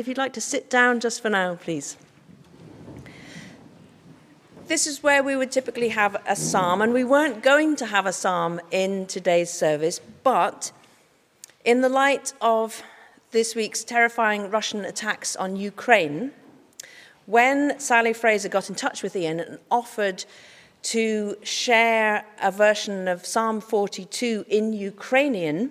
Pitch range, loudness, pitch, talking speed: 190-245 Hz, -23 LUFS, 220 Hz, 140 wpm